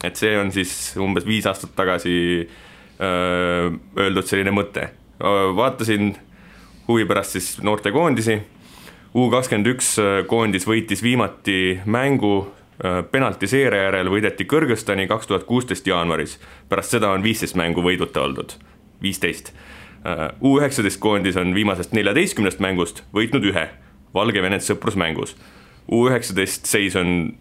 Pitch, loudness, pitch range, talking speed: 100 Hz, -20 LUFS, 90-110 Hz, 110 wpm